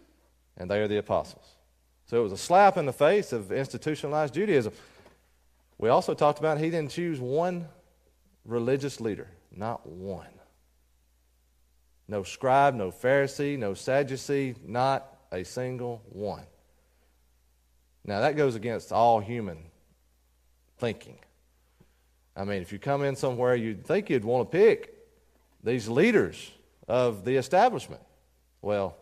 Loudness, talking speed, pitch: -27 LUFS, 130 wpm, 105 Hz